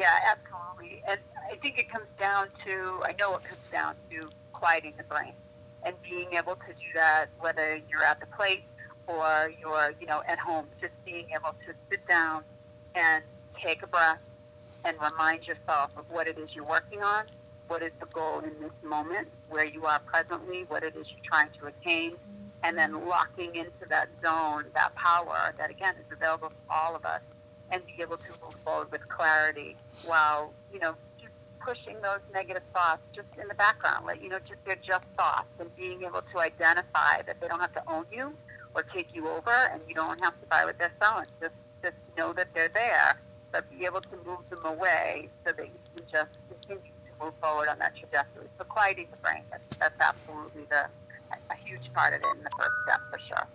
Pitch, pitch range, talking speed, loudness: 160 Hz, 145-180 Hz, 210 wpm, -29 LUFS